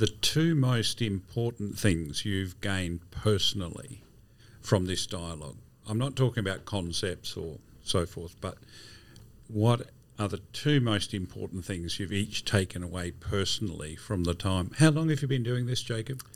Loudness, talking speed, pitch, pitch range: -30 LUFS, 160 wpm, 105 Hz, 95-115 Hz